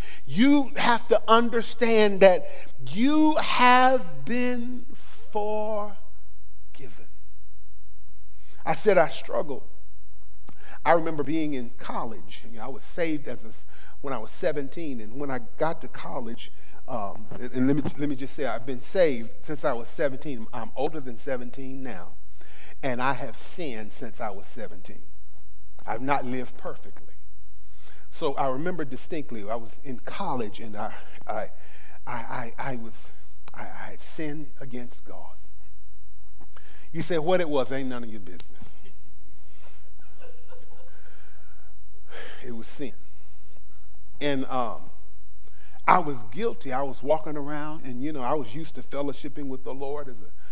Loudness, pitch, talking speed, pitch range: -27 LUFS, 120 Hz, 145 wpm, 95-145 Hz